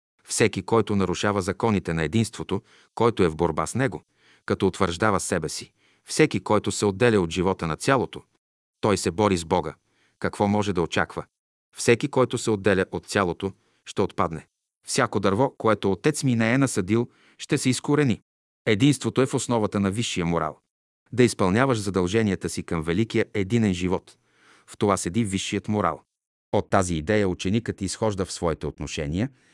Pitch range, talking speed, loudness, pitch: 95-115 Hz, 165 wpm, -24 LUFS, 105 Hz